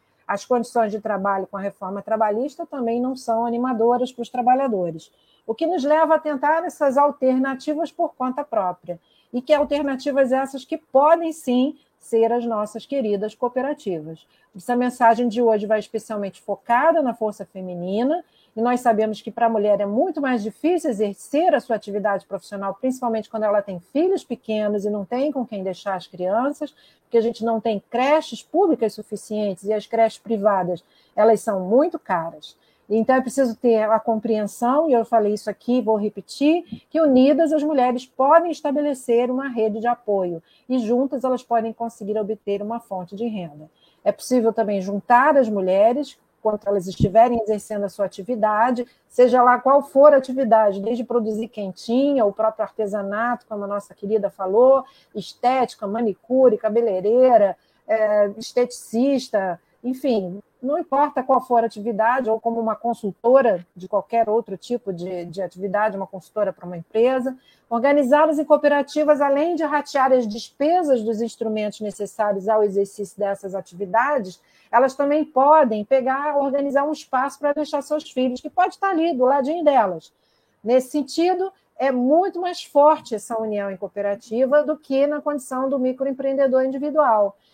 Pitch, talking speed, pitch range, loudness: 235 Hz, 160 wpm, 210-275 Hz, -21 LUFS